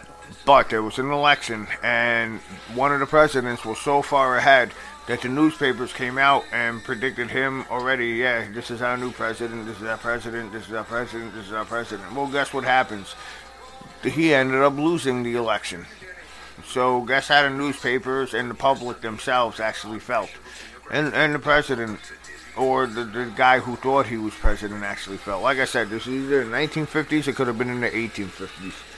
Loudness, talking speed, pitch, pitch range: -22 LUFS, 190 wpm, 125 Hz, 110-135 Hz